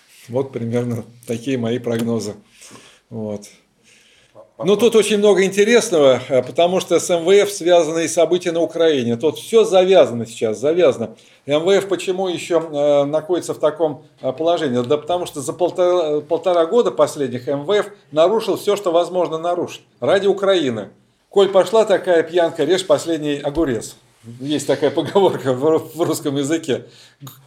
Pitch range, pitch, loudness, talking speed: 135-180 Hz, 160 Hz, -17 LUFS, 135 wpm